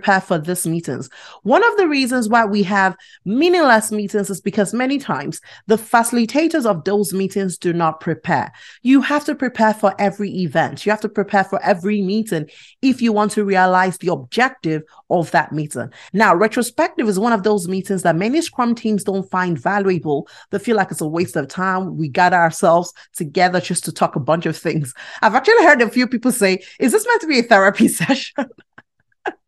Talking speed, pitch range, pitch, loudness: 195 wpm, 175-235 Hz, 200 Hz, -17 LUFS